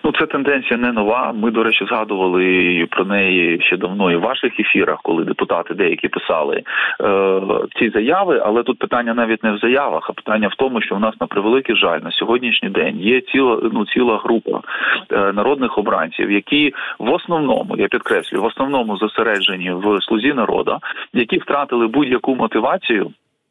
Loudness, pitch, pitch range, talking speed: -17 LUFS, 115 Hz, 95-125 Hz, 170 wpm